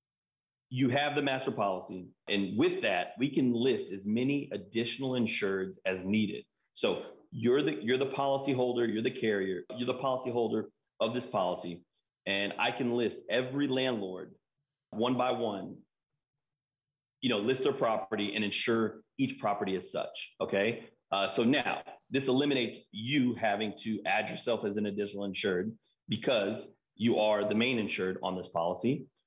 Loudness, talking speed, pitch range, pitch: -32 LUFS, 160 wpm, 105-135 Hz, 120 Hz